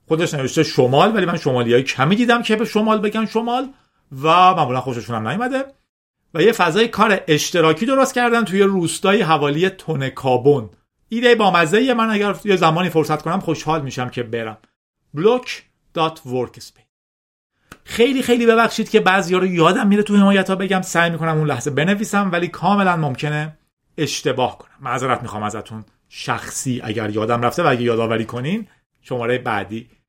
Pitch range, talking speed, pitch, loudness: 125-205 Hz, 160 wpm, 160 Hz, -17 LUFS